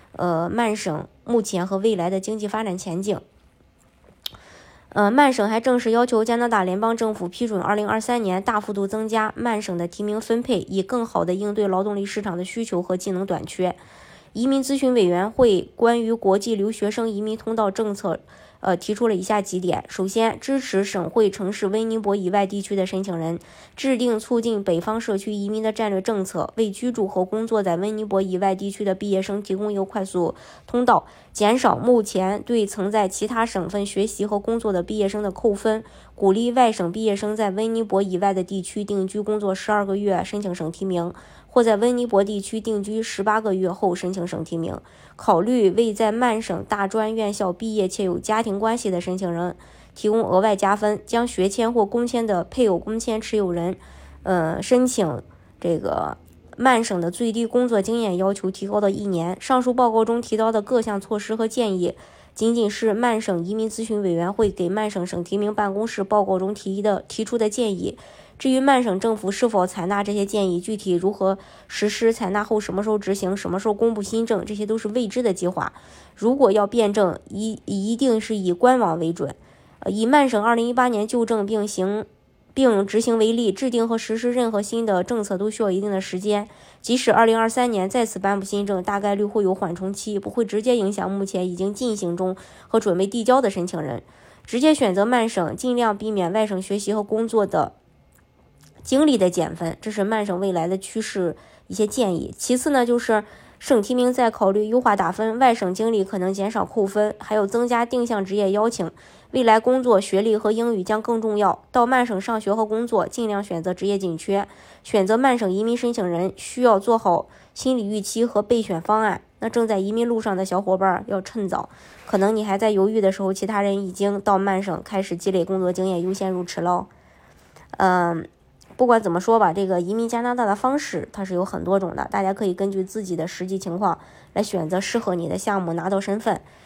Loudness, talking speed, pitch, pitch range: -22 LUFS, 305 characters per minute, 205 Hz, 190-225 Hz